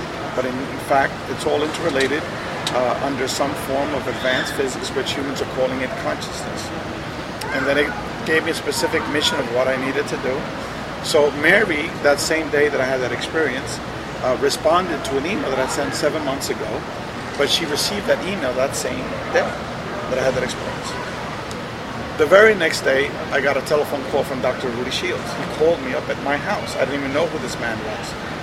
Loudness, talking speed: -21 LUFS, 205 wpm